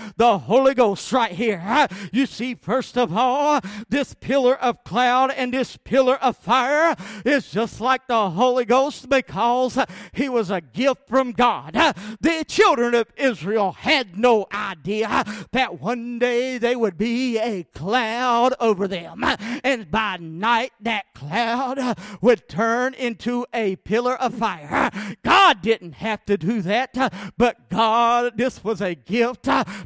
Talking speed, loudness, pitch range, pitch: 145 wpm, -21 LUFS, 210-255 Hz, 235 Hz